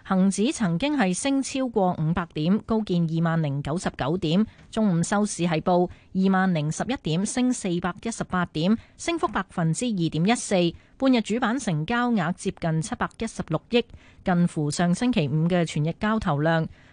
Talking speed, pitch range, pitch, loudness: 265 characters per minute, 165-225 Hz, 185 Hz, -25 LUFS